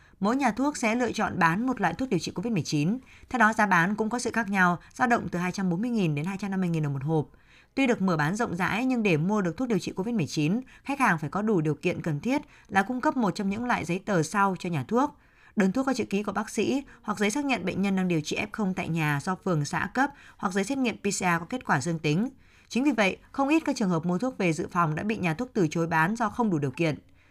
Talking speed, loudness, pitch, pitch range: 275 wpm, -27 LUFS, 195 Hz, 170-235 Hz